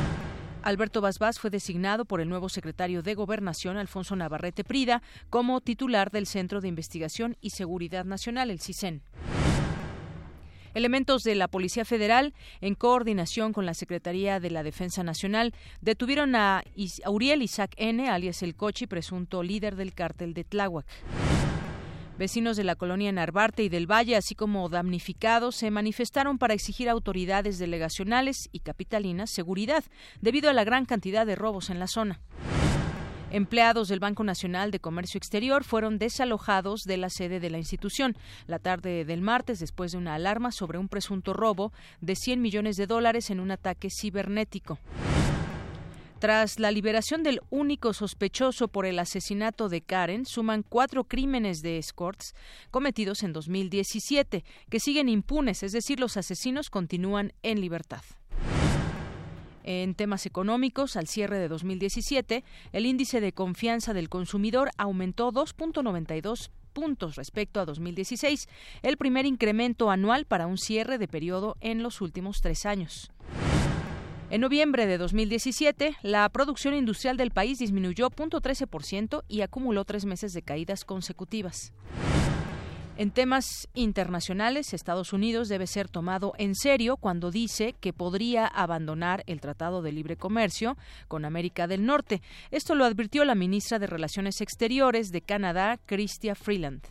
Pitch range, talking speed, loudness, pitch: 185-230 Hz, 145 wpm, -29 LUFS, 205 Hz